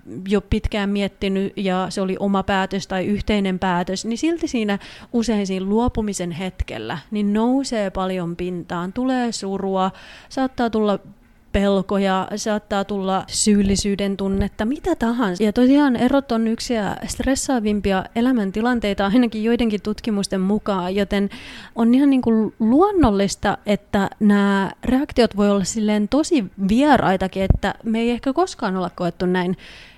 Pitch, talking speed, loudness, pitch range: 205 Hz, 130 wpm, -20 LUFS, 195-235 Hz